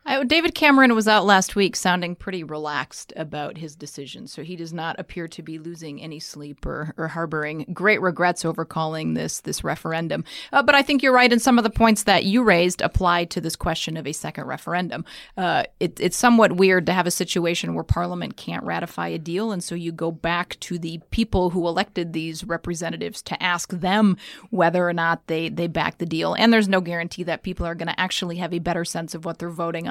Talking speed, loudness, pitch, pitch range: 225 wpm, -22 LUFS, 170 Hz, 165-190 Hz